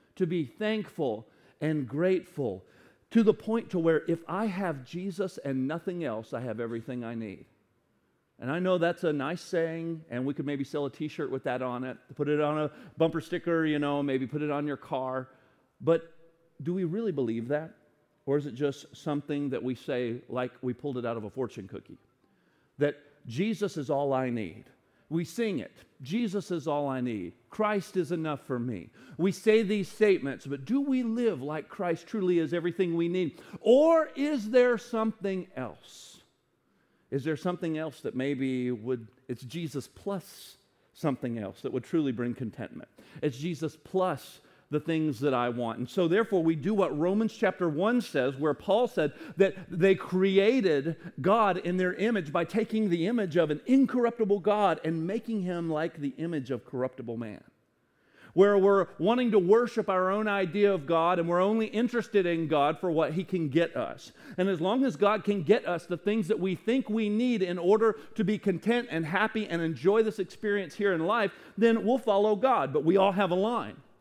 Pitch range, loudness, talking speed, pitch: 145-205 Hz, -29 LUFS, 195 wpm, 170 Hz